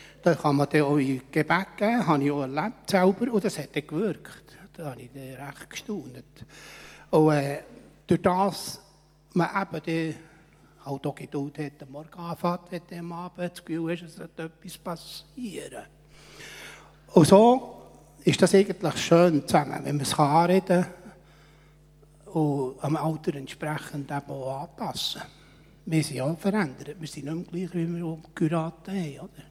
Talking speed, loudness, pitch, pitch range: 165 wpm, -26 LUFS, 160 Hz, 150-175 Hz